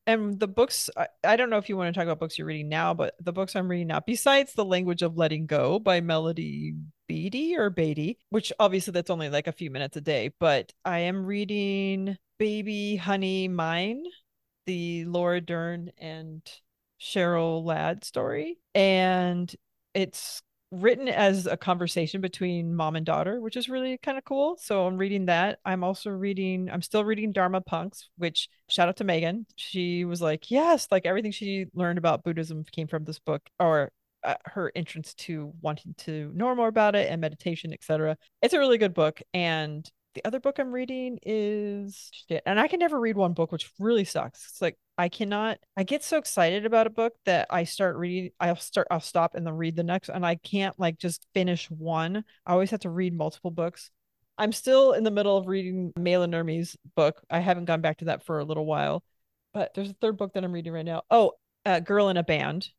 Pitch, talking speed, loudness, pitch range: 180 Hz, 205 wpm, -27 LUFS, 165-205 Hz